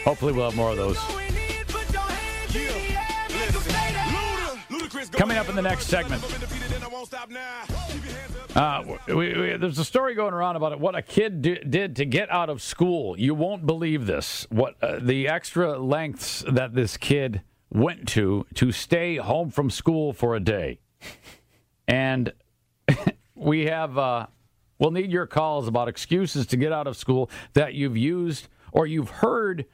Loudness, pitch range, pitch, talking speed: -25 LUFS, 120-175 Hz, 150 Hz, 150 wpm